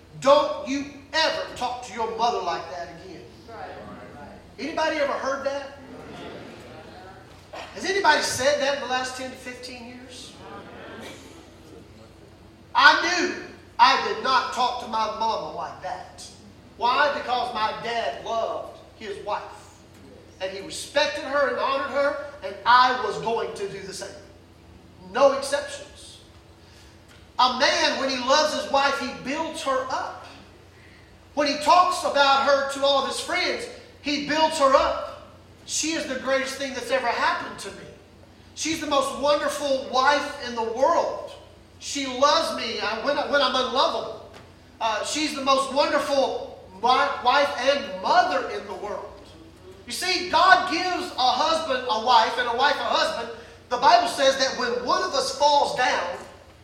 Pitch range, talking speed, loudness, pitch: 245-290 Hz, 155 wpm, -23 LUFS, 275 Hz